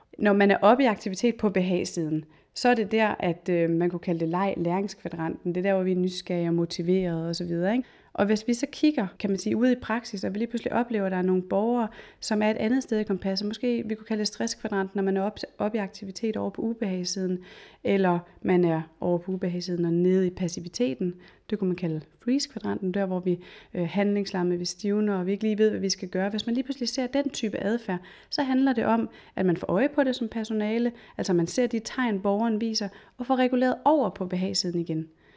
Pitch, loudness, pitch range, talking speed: 200 Hz, -27 LUFS, 180-230 Hz, 235 wpm